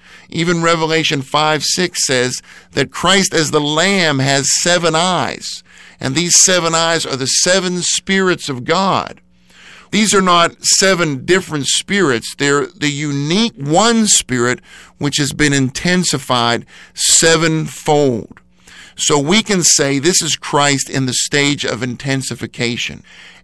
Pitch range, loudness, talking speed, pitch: 135-175 Hz, -13 LUFS, 130 wpm, 155 Hz